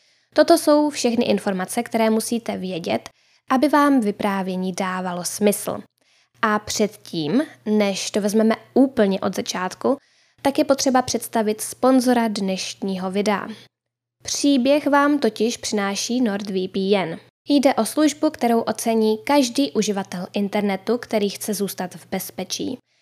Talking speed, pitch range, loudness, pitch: 115 wpm, 195-255 Hz, -21 LUFS, 220 Hz